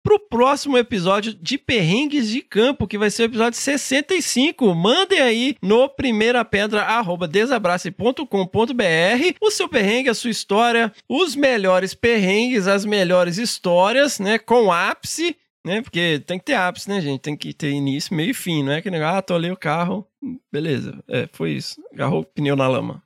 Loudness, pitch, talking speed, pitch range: -19 LUFS, 215 Hz, 170 wpm, 180-255 Hz